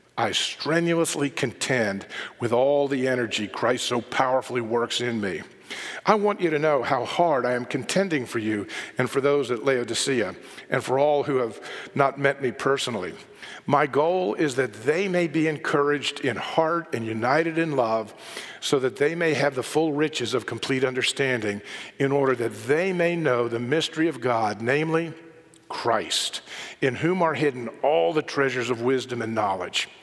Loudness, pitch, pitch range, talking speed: -24 LUFS, 140 Hz, 125-160 Hz, 175 wpm